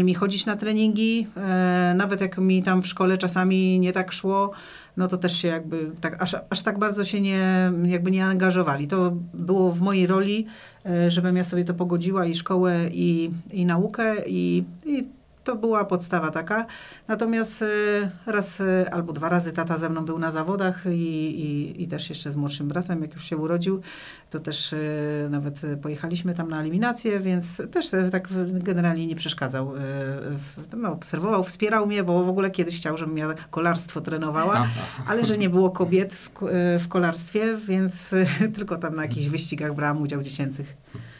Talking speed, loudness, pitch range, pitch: 170 wpm, -24 LUFS, 160-190 Hz, 180 Hz